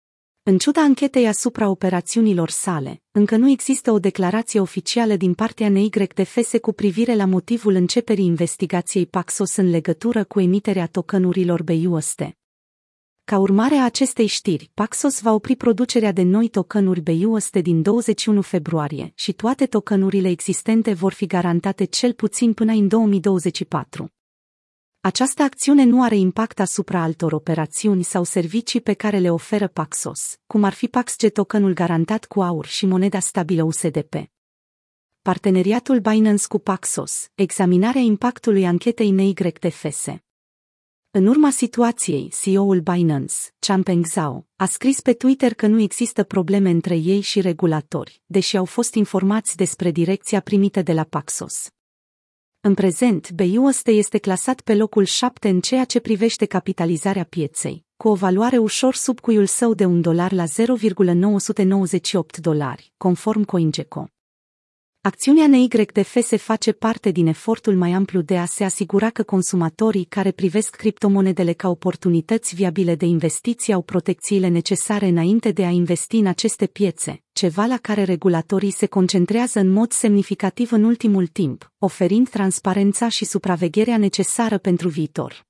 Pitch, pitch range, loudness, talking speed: 195 Hz, 180-220 Hz, -19 LUFS, 140 wpm